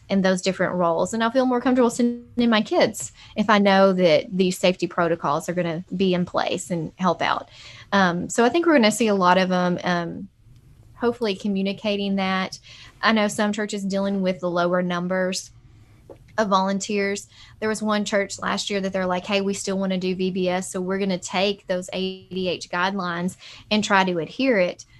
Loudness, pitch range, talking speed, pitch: -22 LUFS, 175-205 Hz, 200 wpm, 190 Hz